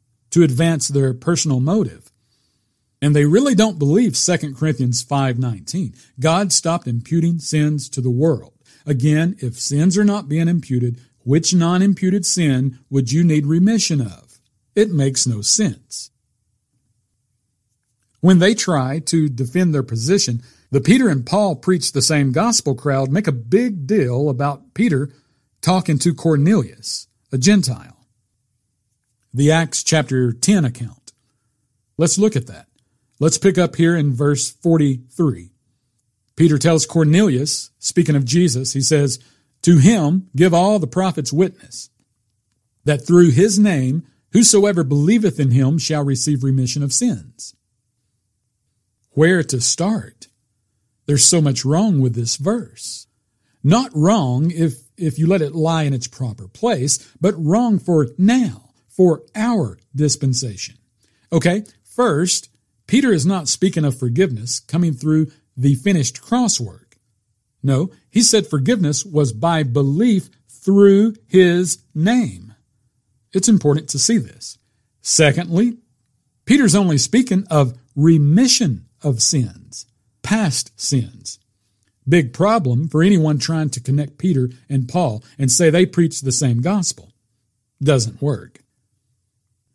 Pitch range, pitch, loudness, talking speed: 120-175 Hz, 140 Hz, -17 LUFS, 130 wpm